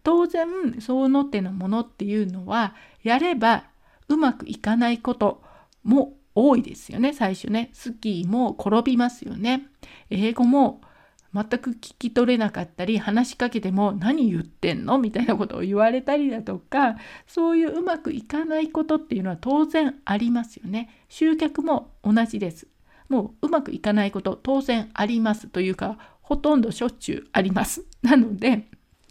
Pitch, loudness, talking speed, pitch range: 240 Hz, -23 LUFS, 330 characters per minute, 215-280 Hz